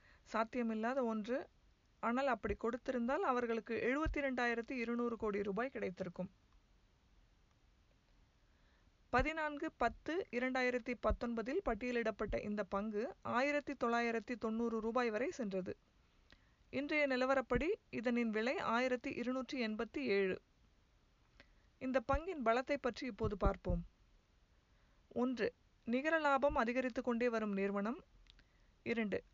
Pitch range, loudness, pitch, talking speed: 225-265 Hz, -39 LUFS, 245 Hz, 95 wpm